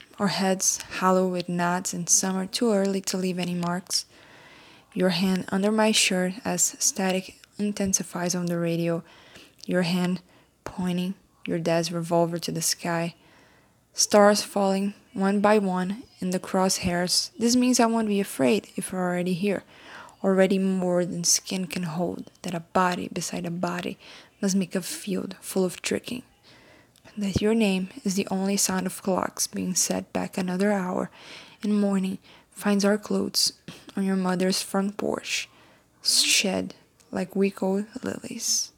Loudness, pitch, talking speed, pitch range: -25 LUFS, 190 Hz, 155 wpm, 180-200 Hz